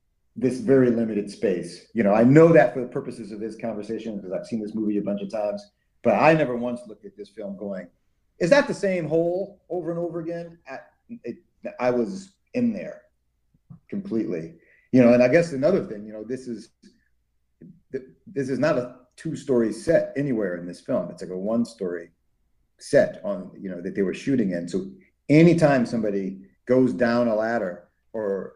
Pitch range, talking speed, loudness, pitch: 105-165 Hz, 195 wpm, -23 LUFS, 125 Hz